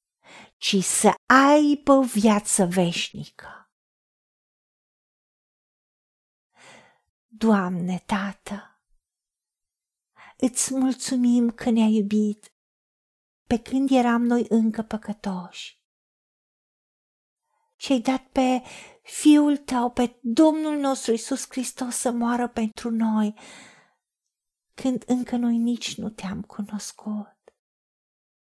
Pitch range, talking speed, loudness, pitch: 215-260 Hz, 85 wpm, -23 LUFS, 235 Hz